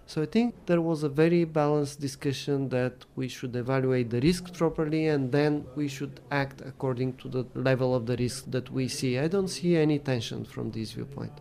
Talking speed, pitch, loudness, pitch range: 205 wpm, 140 Hz, -28 LUFS, 130-155 Hz